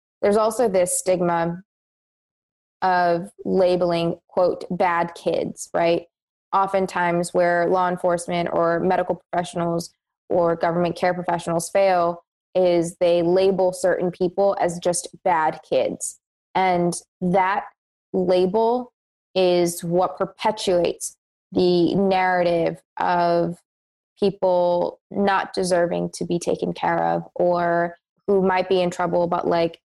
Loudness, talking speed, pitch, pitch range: -21 LUFS, 110 wpm, 180 Hz, 170-185 Hz